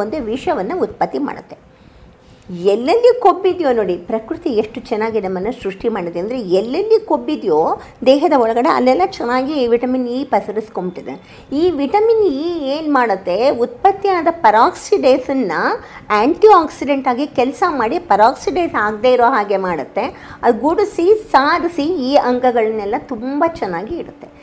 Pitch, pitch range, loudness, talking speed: 265 Hz, 230-340 Hz, -16 LUFS, 115 wpm